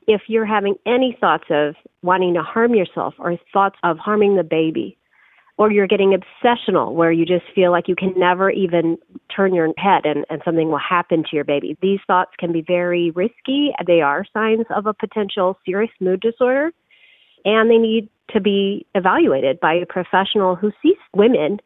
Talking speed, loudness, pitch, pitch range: 185 wpm, -18 LUFS, 190 Hz, 175-215 Hz